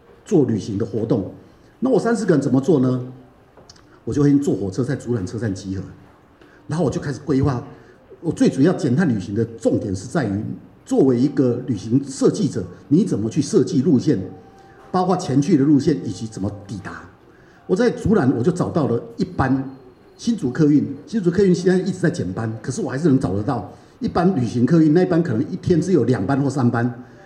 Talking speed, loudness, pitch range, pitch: 300 characters per minute, -20 LUFS, 115-155 Hz, 135 Hz